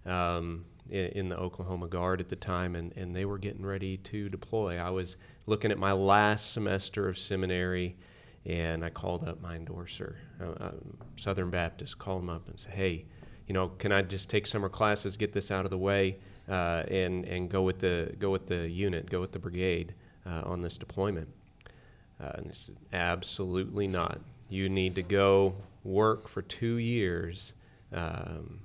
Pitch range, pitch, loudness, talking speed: 90-100 Hz, 95 Hz, -32 LUFS, 185 wpm